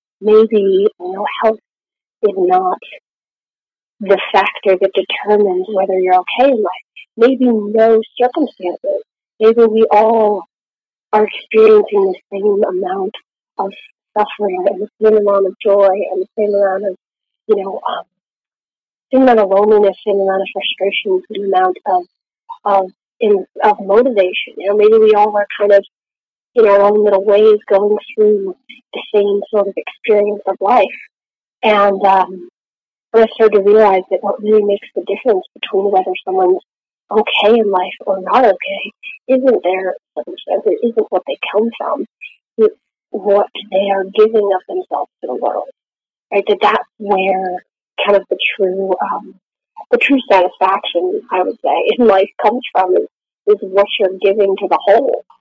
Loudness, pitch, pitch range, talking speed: -14 LUFS, 210 Hz, 195-250 Hz, 160 wpm